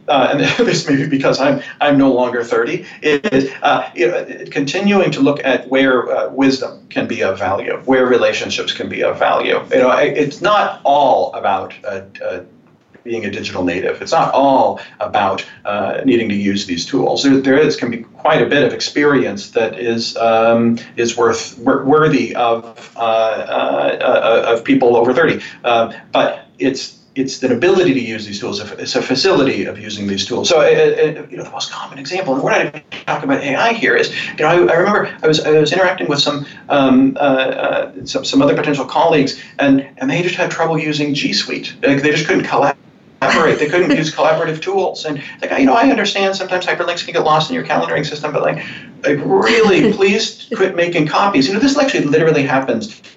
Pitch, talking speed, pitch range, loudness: 145 Hz, 210 wpm, 125-185 Hz, -15 LUFS